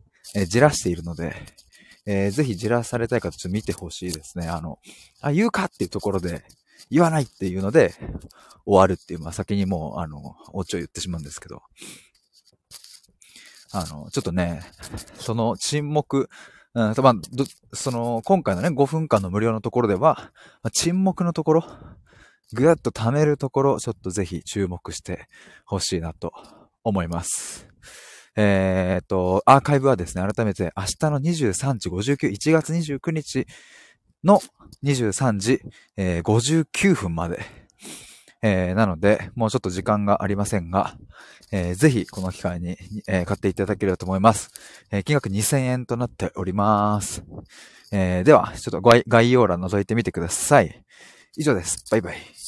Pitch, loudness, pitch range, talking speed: 105 Hz, -22 LUFS, 90-130 Hz, 310 characters per minute